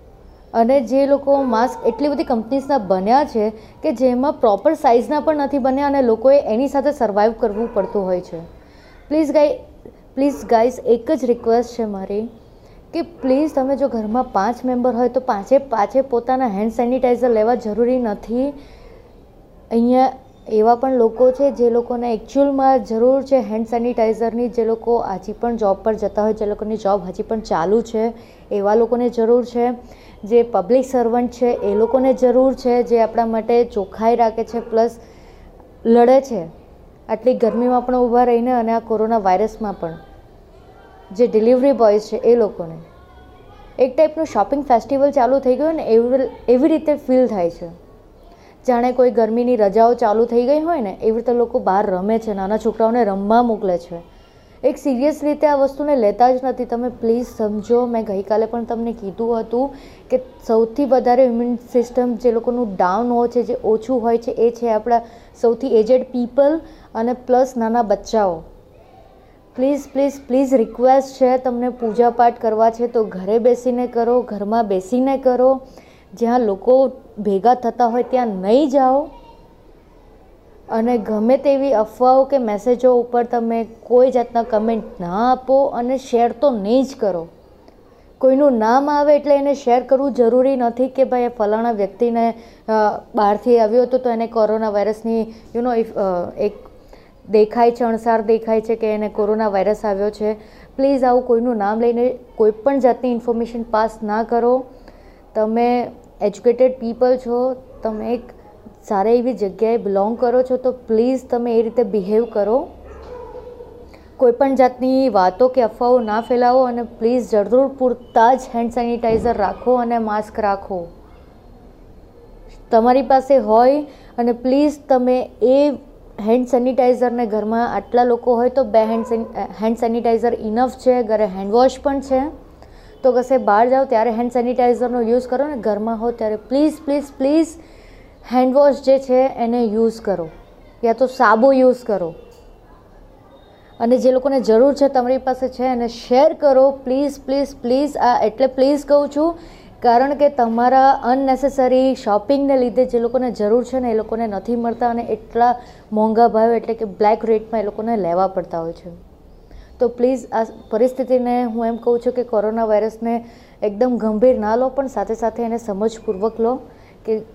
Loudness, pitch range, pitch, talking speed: -17 LUFS, 225-255 Hz, 240 Hz, 160 wpm